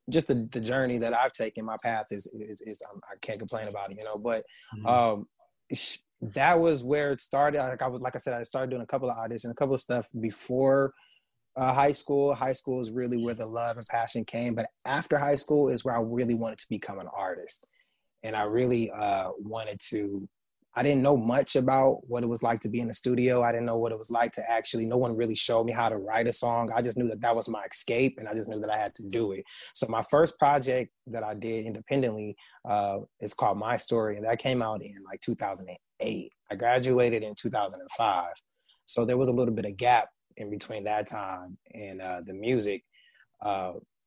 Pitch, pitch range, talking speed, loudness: 120 Hz, 110-130 Hz, 230 wpm, -28 LUFS